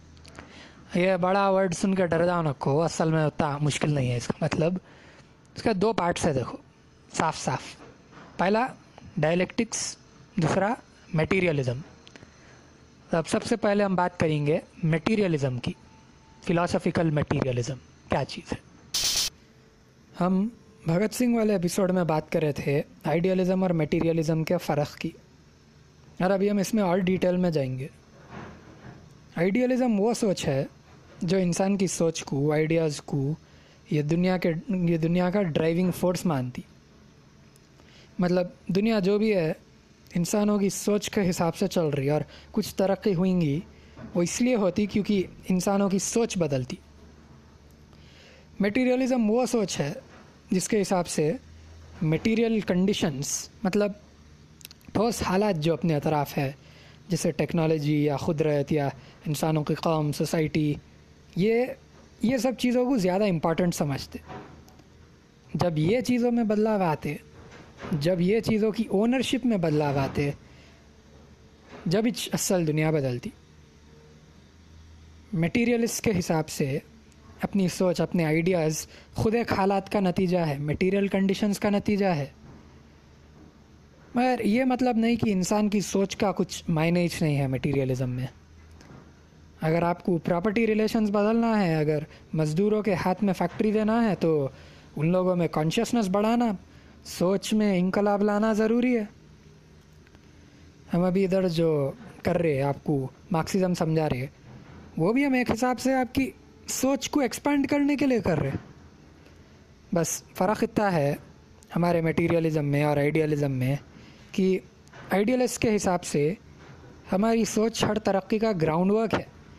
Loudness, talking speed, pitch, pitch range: -26 LUFS, 140 wpm, 175 Hz, 145-205 Hz